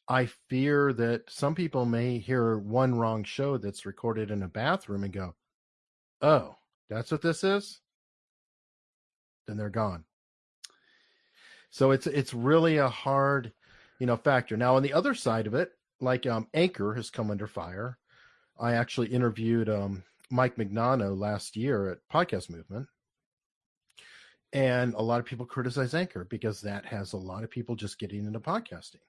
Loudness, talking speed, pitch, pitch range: -29 LUFS, 160 wpm, 120 Hz, 105-130 Hz